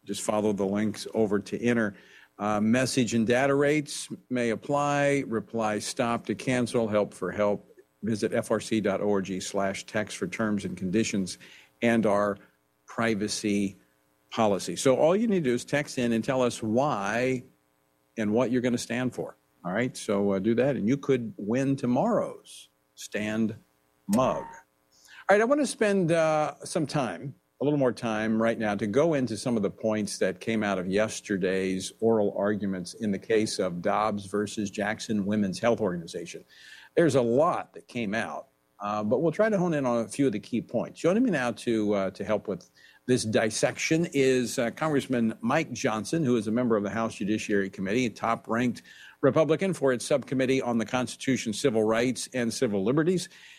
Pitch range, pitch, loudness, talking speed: 105-130 Hz, 115 Hz, -27 LUFS, 185 wpm